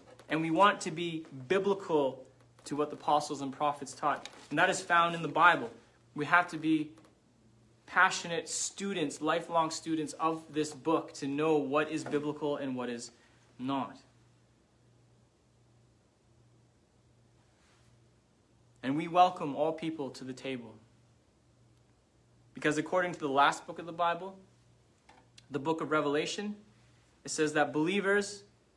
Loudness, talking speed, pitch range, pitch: -31 LUFS, 135 wpm, 120-160 Hz, 150 Hz